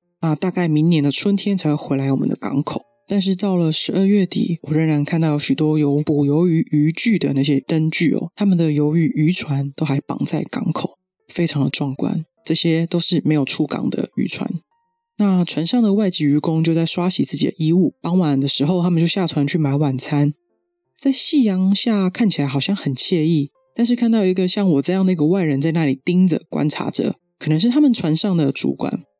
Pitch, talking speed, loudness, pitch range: 165 Hz, 305 characters per minute, -18 LUFS, 145-185 Hz